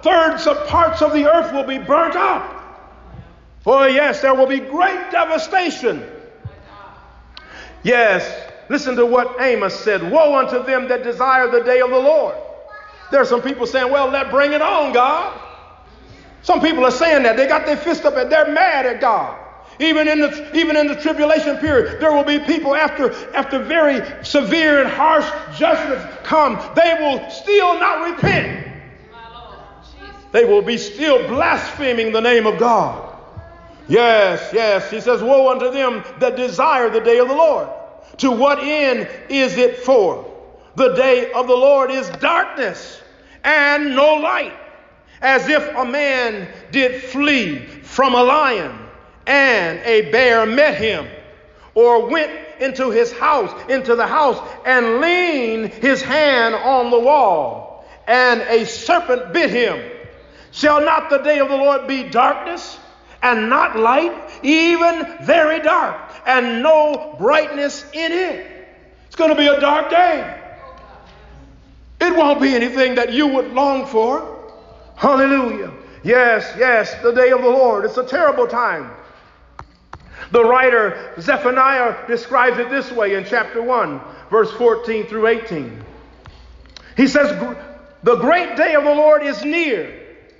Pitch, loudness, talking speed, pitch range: 280 Hz, -15 LUFS, 155 wpm, 250-315 Hz